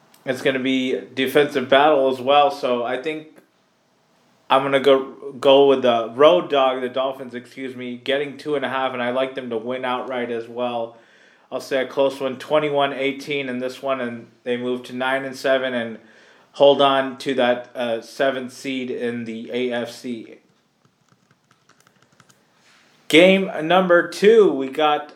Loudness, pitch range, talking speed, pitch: -20 LUFS, 125-140 Hz, 165 wpm, 130 Hz